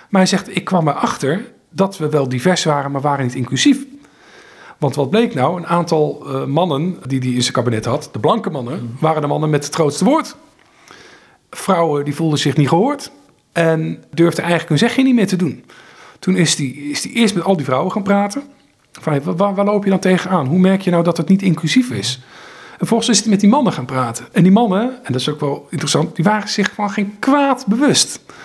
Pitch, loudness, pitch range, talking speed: 175 Hz, -16 LUFS, 145-210 Hz, 230 wpm